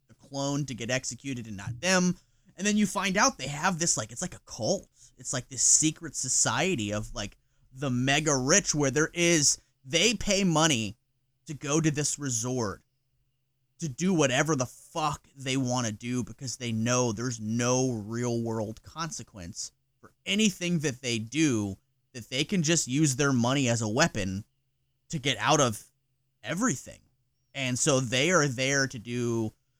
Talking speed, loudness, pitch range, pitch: 170 wpm, -27 LUFS, 120-150 Hz, 130 Hz